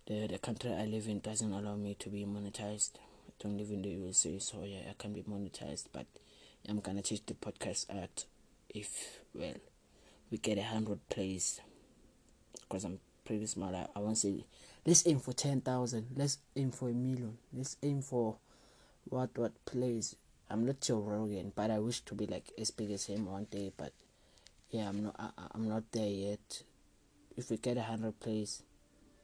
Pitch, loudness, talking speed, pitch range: 105 Hz, -38 LUFS, 190 wpm, 100-115 Hz